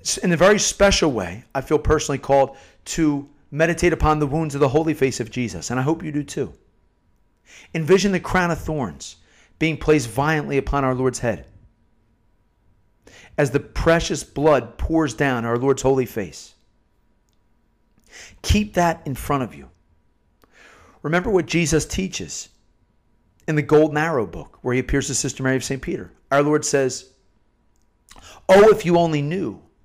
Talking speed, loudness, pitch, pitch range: 160 wpm, -20 LUFS, 145 Hz, 125-160 Hz